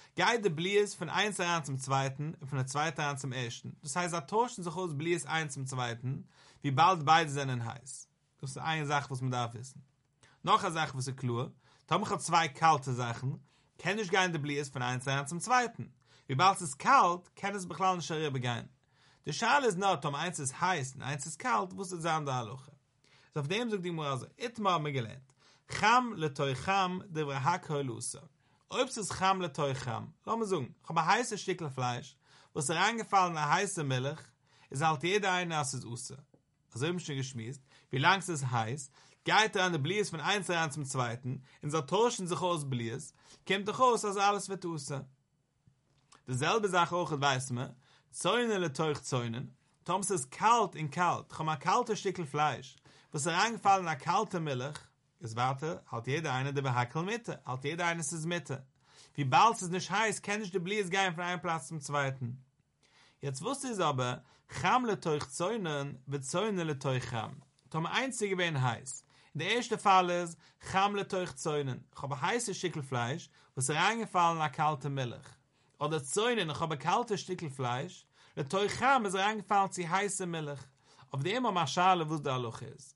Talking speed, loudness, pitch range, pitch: 180 wpm, -32 LUFS, 135-185 Hz, 155 Hz